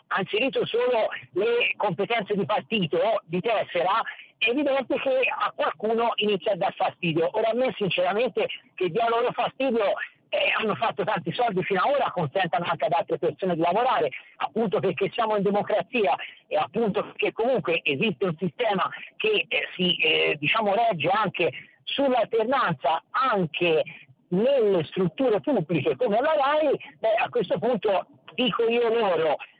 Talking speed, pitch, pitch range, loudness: 155 wpm, 220 Hz, 185-270 Hz, -25 LUFS